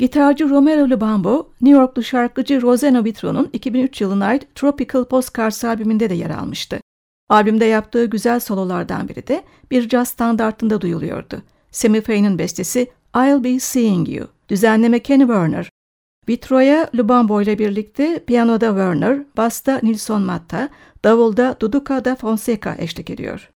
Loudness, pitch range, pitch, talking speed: -17 LUFS, 215-260 Hz, 235 Hz, 130 wpm